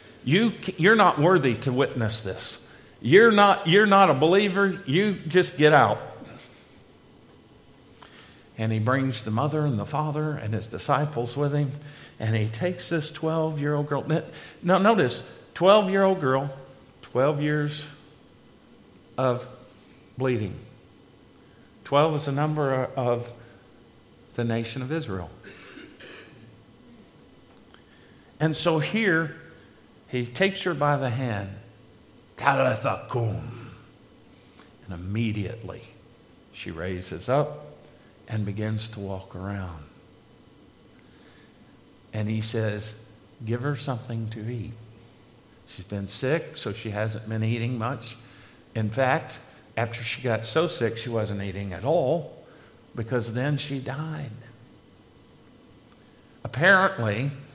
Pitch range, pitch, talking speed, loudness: 110-150 Hz, 125 Hz, 110 wpm, -25 LUFS